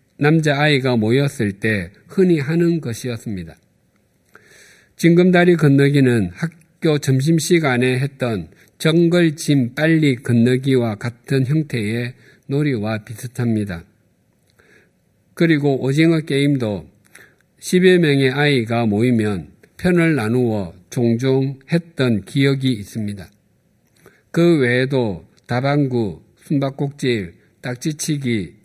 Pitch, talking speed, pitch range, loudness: 130 Hz, 225 characters per minute, 115-150 Hz, -18 LUFS